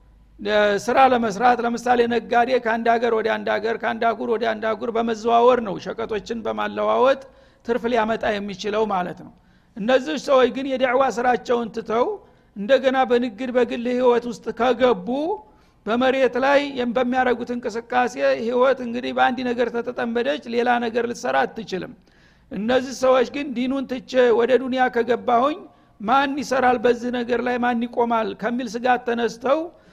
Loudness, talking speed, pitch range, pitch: -21 LUFS, 130 wpm, 230-255 Hz, 245 Hz